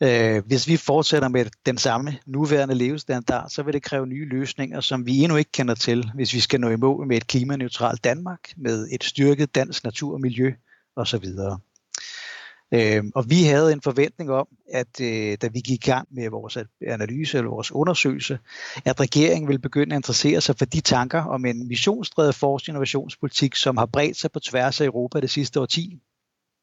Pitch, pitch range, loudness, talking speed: 135 Hz, 120-145 Hz, -22 LUFS, 185 wpm